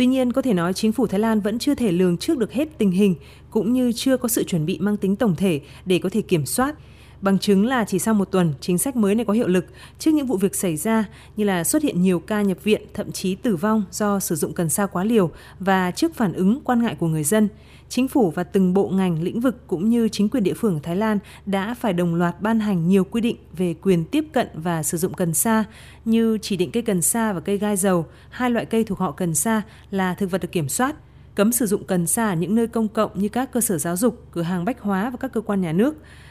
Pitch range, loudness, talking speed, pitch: 185-225 Hz, -21 LUFS, 275 wpm, 205 Hz